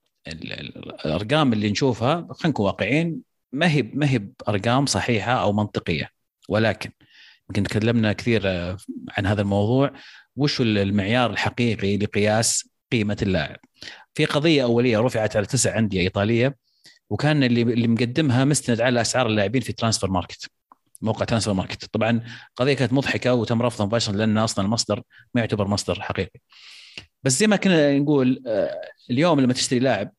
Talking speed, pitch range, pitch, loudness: 140 wpm, 105-135 Hz, 115 Hz, -22 LUFS